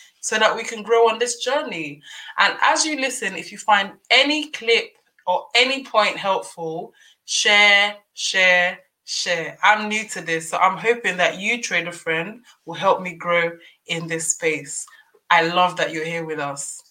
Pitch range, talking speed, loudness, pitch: 170-230 Hz, 175 wpm, -19 LUFS, 195 Hz